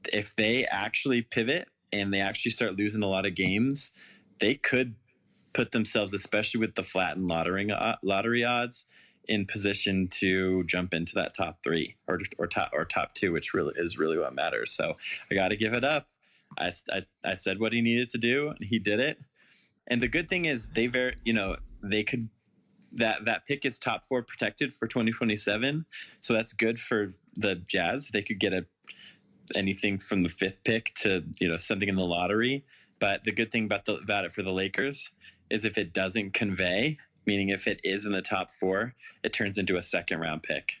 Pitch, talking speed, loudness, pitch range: 105 Hz, 200 wpm, -28 LUFS, 95-120 Hz